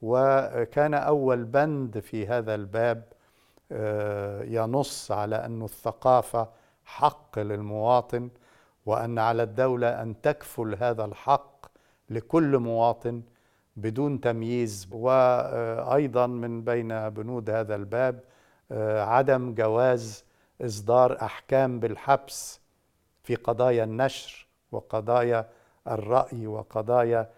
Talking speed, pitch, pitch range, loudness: 90 wpm, 120 Hz, 110-130 Hz, -26 LUFS